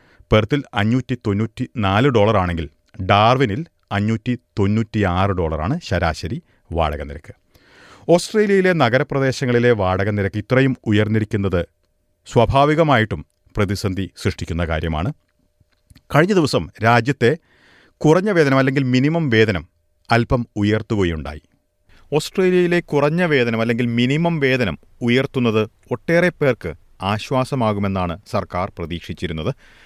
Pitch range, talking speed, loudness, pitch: 95-135 Hz, 90 wpm, -19 LUFS, 110 Hz